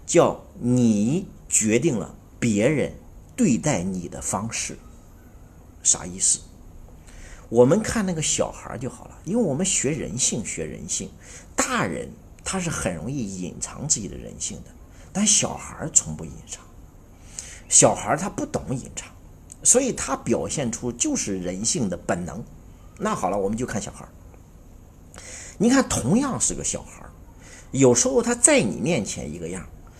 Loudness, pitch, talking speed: -22 LUFS, 115 Hz, 210 characters per minute